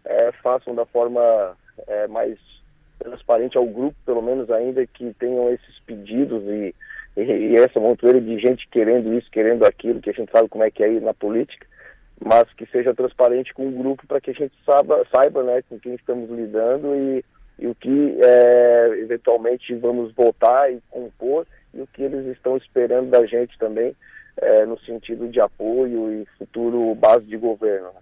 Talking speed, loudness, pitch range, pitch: 180 wpm, -19 LUFS, 115-130 Hz, 120 Hz